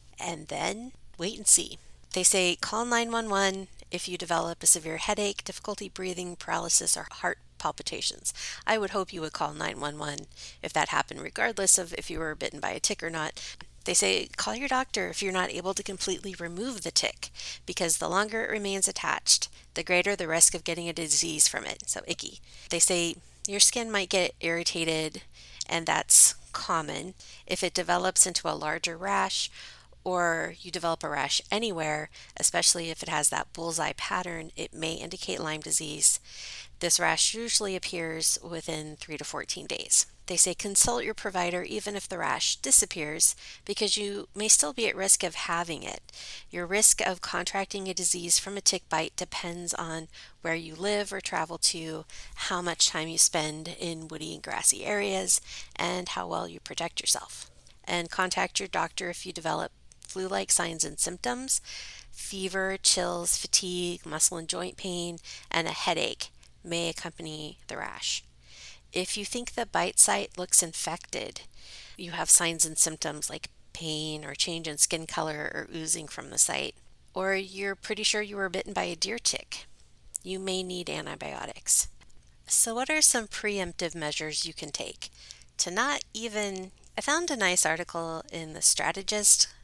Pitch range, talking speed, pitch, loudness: 160-195 Hz, 170 wpm, 175 Hz, -26 LUFS